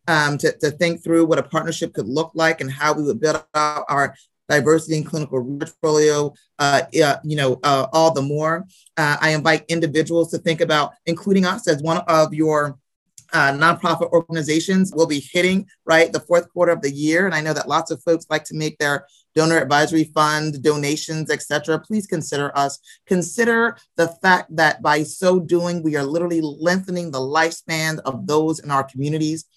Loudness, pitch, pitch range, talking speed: -19 LUFS, 160 Hz, 150-165 Hz, 190 wpm